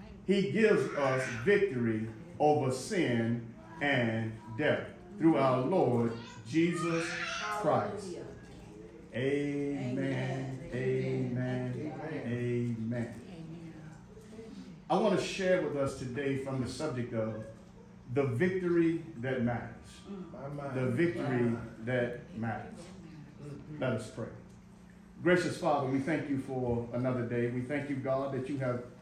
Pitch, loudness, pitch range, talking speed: 135 Hz, -32 LUFS, 120-165 Hz, 110 wpm